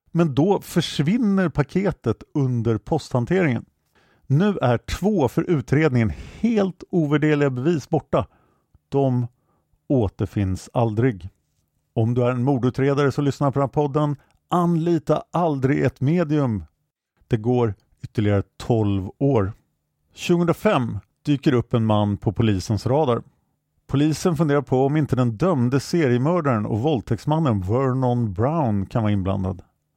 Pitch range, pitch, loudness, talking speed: 115-155 Hz, 135 Hz, -22 LUFS, 120 wpm